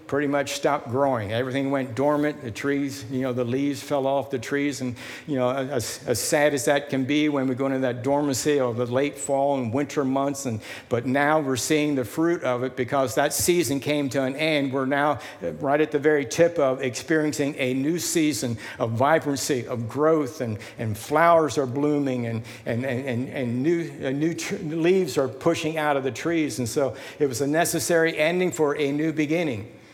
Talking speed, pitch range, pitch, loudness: 210 wpm, 130-150 Hz, 140 Hz, -24 LUFS